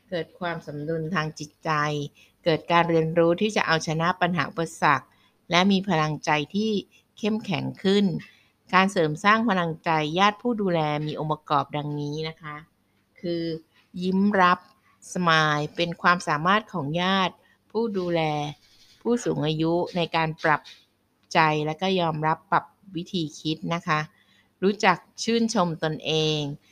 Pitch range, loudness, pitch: 150-185 Hz, -24 LUFS, 165 Hz